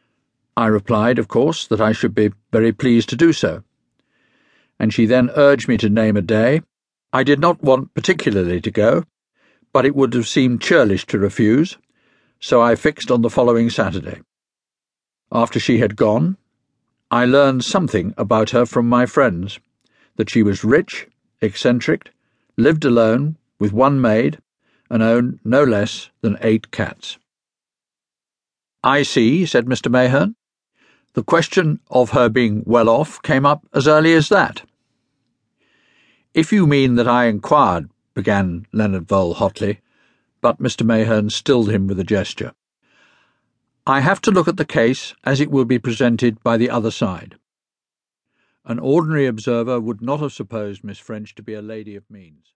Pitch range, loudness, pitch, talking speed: 110-135 Hz, -17 LUFS, 120 Hz, 160 wpm